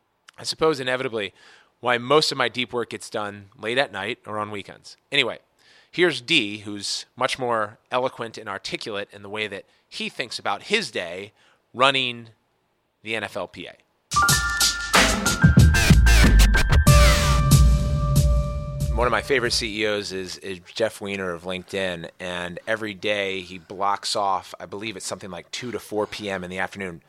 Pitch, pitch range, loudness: 105 Hz, 90-120 Hz, -22 LUFS